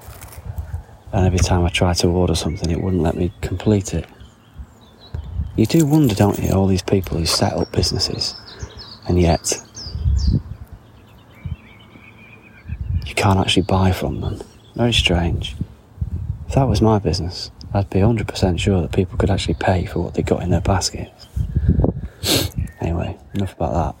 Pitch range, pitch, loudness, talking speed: 90-105 Hz, 95 Hz, -19 LUFS, 155 wpm